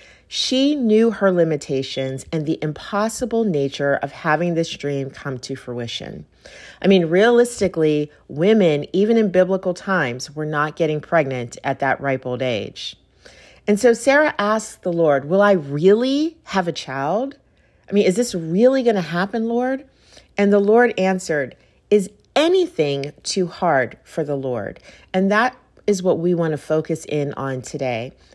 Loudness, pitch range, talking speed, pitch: -19 LUFS, 145-215 Hz, 160 wpm, 175 Hz